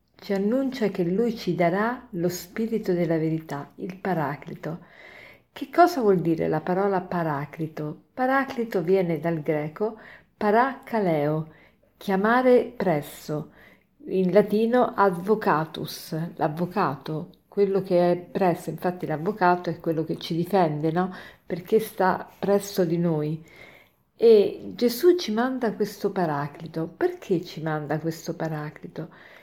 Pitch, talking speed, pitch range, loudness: 180 Hz, 120 wpm, 165-215 Hz, -25 LUFS